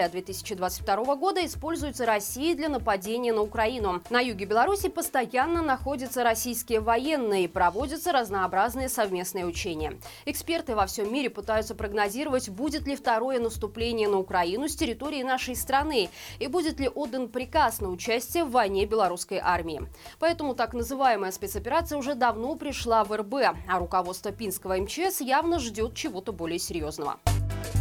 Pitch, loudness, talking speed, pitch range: 235 Hz, -28 LUFS, 140 wpm, 200-280 Hz